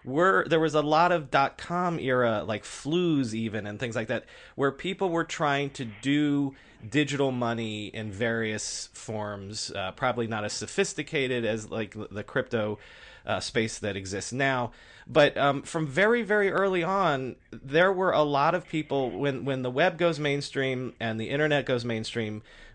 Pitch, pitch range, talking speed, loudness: 135 Hz, 110-155 Hz, 170 wpm, -27 LUFS